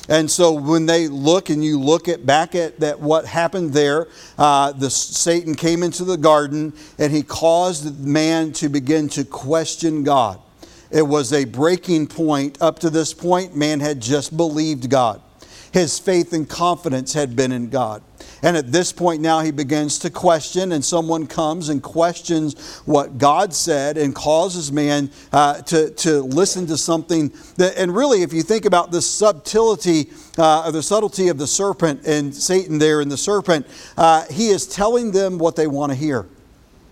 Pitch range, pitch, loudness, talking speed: 150-170 Hz, 160 Hz, -18 LUFS, 180 wpm